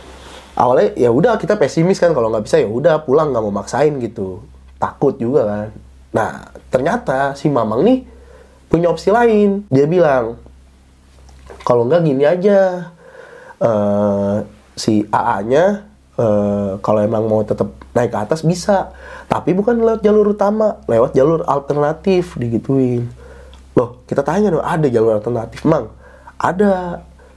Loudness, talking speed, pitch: -16 LUFS, 140 wpm, 145 Hz